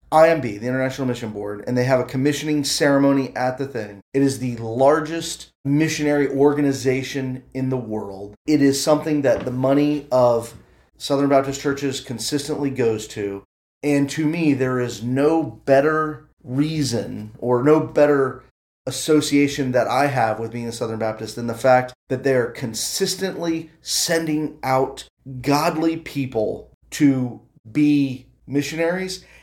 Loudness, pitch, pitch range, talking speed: -21 LUFS, 135 Hz, 125-150 Hz, 145 wpm